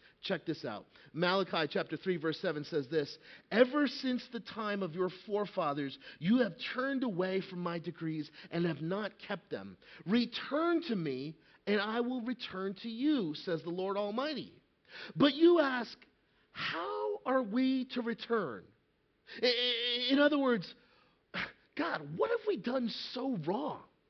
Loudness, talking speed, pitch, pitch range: -34 LUFS, 150 wpm, 210 Hz, 175-255 Hz